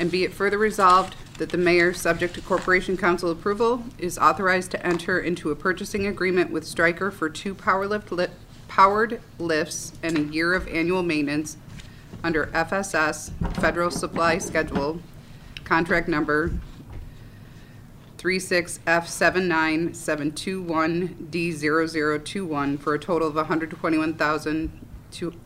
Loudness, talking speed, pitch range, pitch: -23 LUFS, 115 wpm, 155-185 Hz, 170 Hz